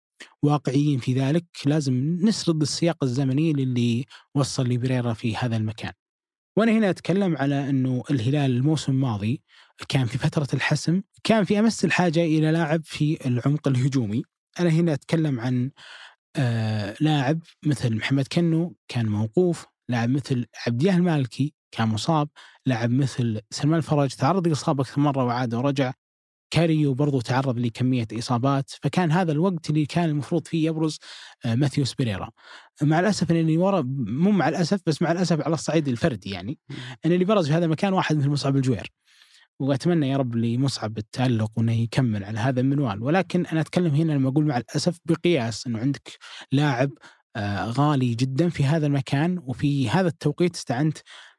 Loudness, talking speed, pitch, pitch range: -24 LUFS, 155 wpm, 145 Hz, 125-165 Hz